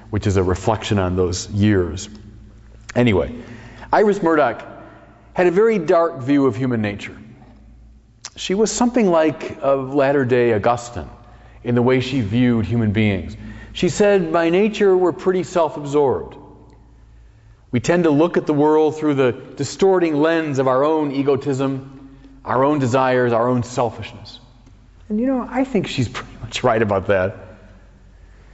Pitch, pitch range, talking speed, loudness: 130 Hz, 110-155 Hz, 155 wpm, -18 LUFS